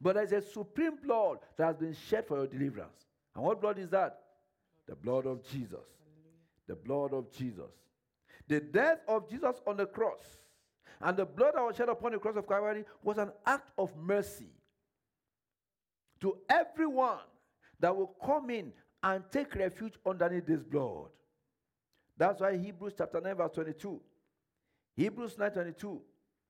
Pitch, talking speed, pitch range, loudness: 195 Hz, 160 wpm, 160-220 Hz, -34 LUFS